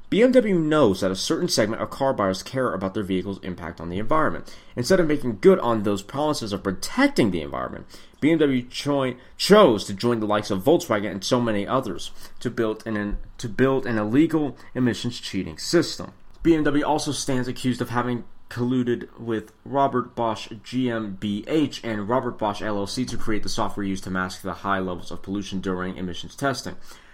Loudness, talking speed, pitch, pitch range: -24 LUFS, 180 wpm, 115 Hz, 100-135 Hz